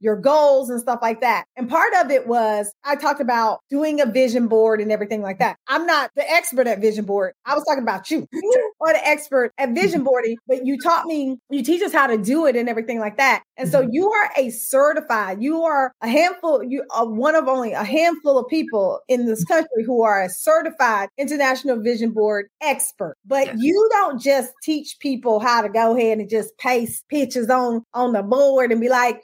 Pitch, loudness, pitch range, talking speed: 260 Hz, -19 LUFS, 230-290 Hz, 220 wpm